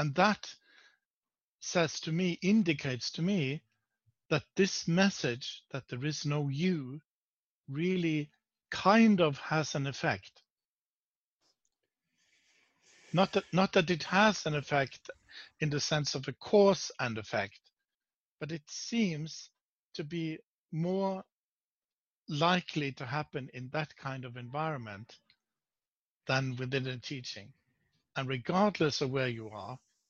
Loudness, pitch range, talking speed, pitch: -32 LUFS, 135-185 Hz, 125 wpm, 155 Hz